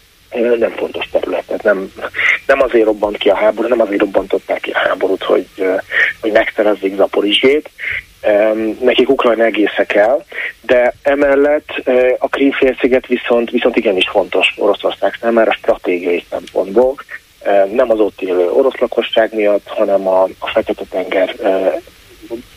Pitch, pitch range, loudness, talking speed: 115 Hz, 105-125 Hz, -14 LUFS, 130 wpm